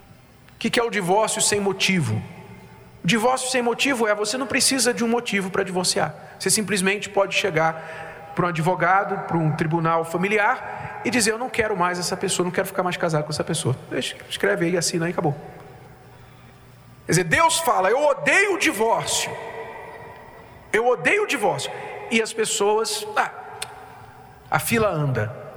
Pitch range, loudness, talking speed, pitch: 165-225 Hz, -21 LUFS, 170 wpm, 195 Hz